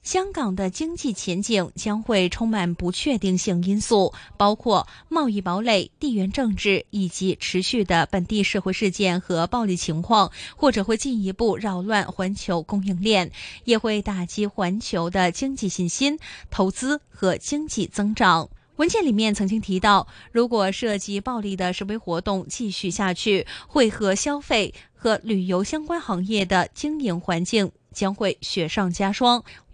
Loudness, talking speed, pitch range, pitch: -23 LUFS, 240 characters per minute, 185-230 Hz, 205 Hz